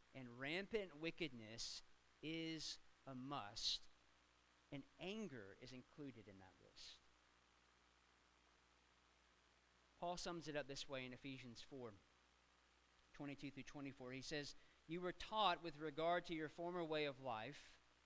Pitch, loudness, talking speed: 125 Hz, -50 LUFS, 125 wpm